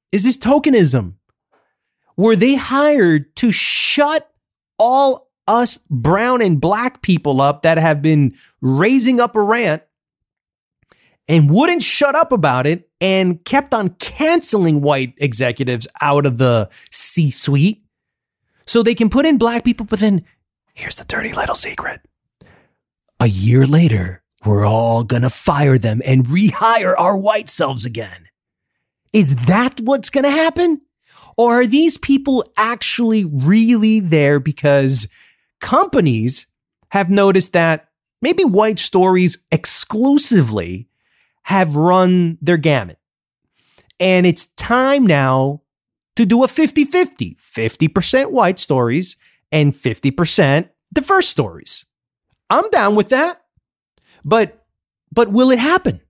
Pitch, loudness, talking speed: 185 Hz, -14 LUFS, 125 wpm